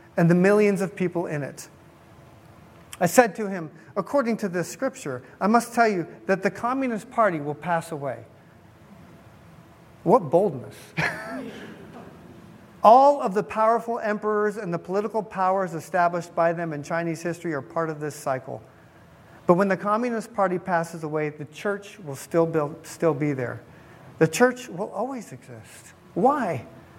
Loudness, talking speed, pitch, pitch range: -24 LUFS, 150 wpm, 180 Hz, 160-210 Hz